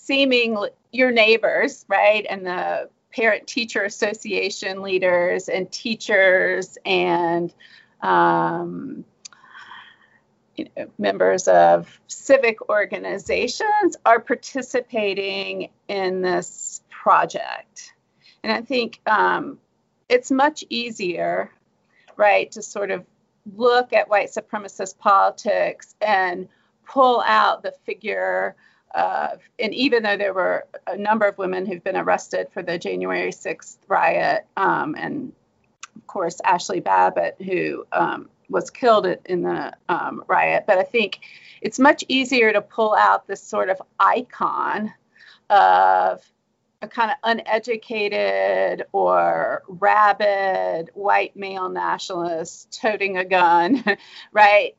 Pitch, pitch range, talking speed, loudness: 205 Hz, 185-235 Hz, 115 wpm, -20 LUFS